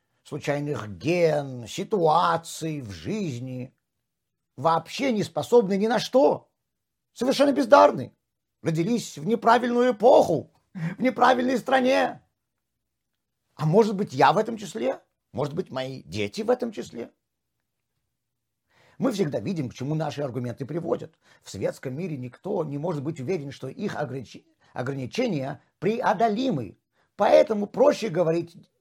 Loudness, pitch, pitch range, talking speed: -24 LUFS, 165 Hz, 140-225 Hz, 120 wpm